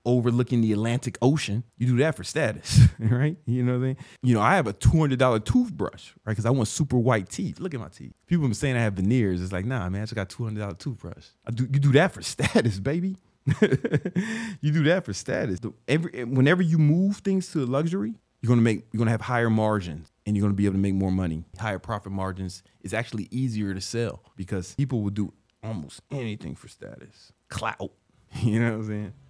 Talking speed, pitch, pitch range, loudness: 230 wpm, 115 Hz, 105-135 Hz, -25 LUFS